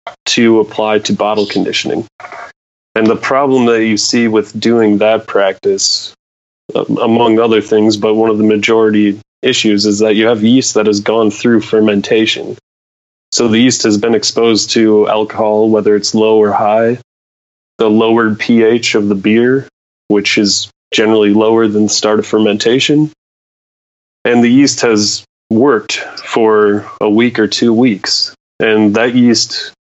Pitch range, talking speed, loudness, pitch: 105-115 Hz, 150 wpm, -11 LUFS, 110 Hz